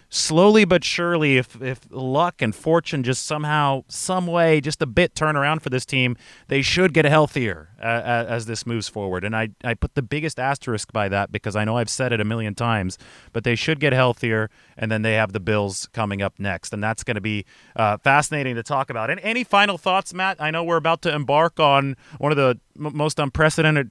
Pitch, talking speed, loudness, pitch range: 130 Hz, 225 wpm, -21 LUFS, 110-155 Hz